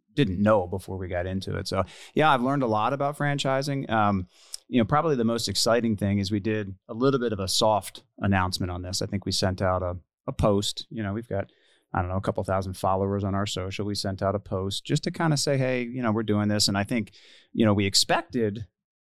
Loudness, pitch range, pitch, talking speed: -26 LUFS, 95-115 Hz, 105 Hz, 250 wpm